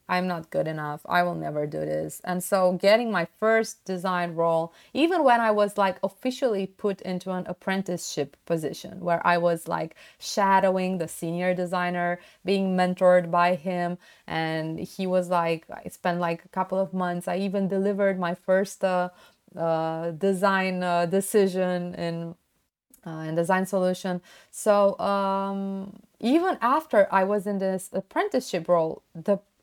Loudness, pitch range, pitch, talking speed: -26 LUFS, 175-195 Hz, 185 Hz, 155 wpm